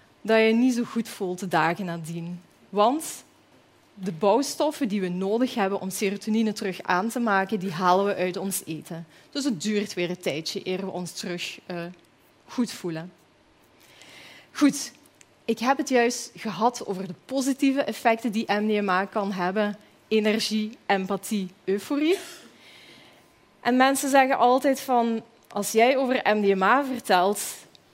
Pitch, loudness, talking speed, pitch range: 210 Hz, -25 LUFS, 150 wpm, 185-240 Hz